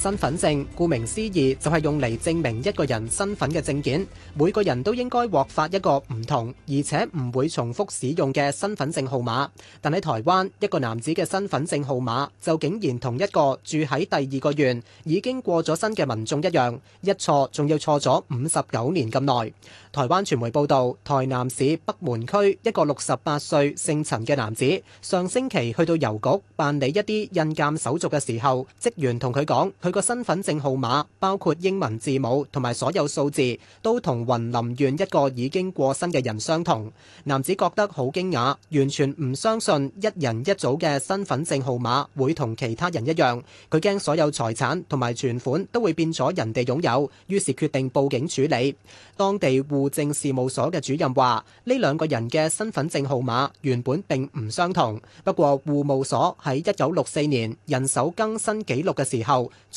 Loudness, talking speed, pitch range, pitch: -24 LUFS, 280 characters per minute, 130-170 Hz, 145 Hz